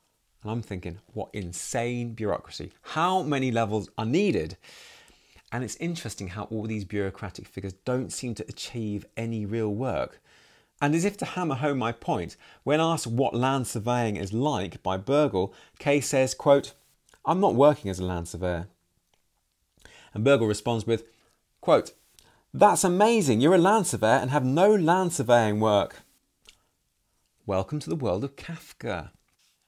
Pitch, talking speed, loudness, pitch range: 120 Hz, 155 wpm, -26 LUFS, 105-145 Hz